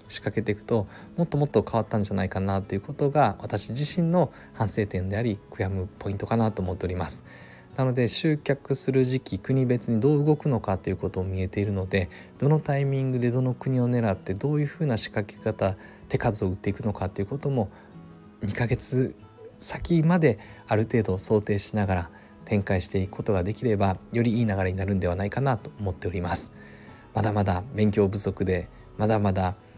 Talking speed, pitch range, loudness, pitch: 405 characters per minute, 95-130 Hz, -26 LUFS, 110 Hz